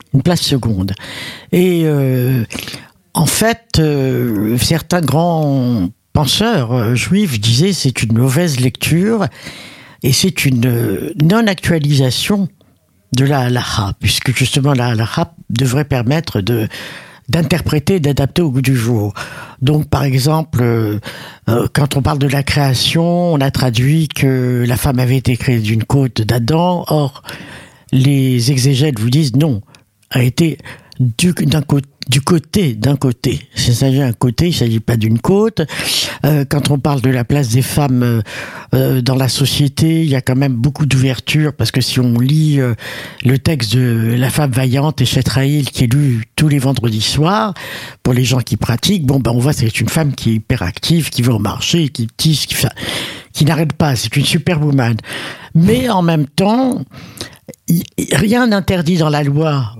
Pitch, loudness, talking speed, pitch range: 135 Hz, -14 LUFS, 165 wpm, 125-155 Hz